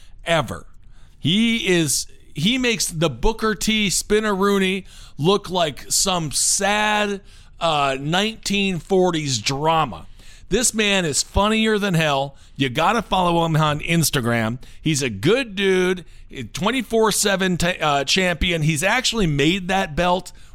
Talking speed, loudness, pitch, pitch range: 125 wpm, -19 LUFS, 175 Hz, 140-200 Hz